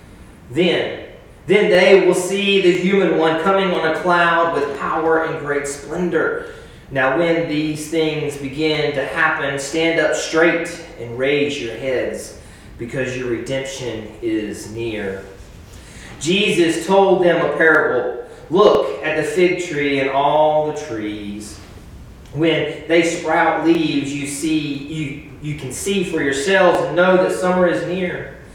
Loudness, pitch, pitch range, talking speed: -17 LUFS, 160 Hz, 140-175 Hz, 145 wpm